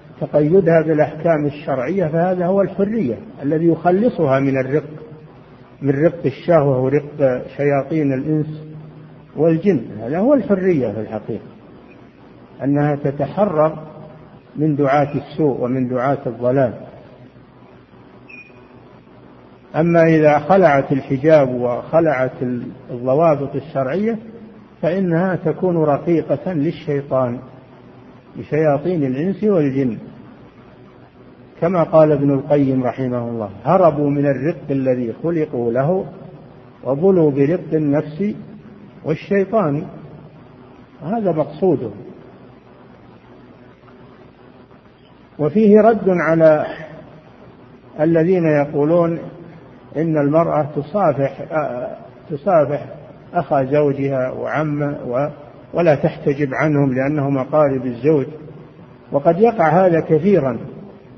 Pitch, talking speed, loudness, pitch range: 150 Hz, 80 wpm, -17 LUFS, 135-165 Hz